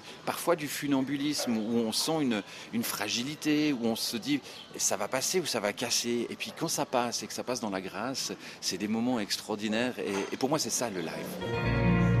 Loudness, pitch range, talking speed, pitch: -30 LUFS, 110-145 Hz, 215 wpm, 120 Hz